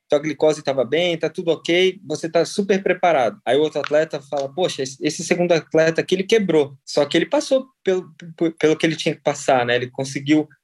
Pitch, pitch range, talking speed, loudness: 160 Hz, 150-175 Hz, 215 wpm, -20 LUFS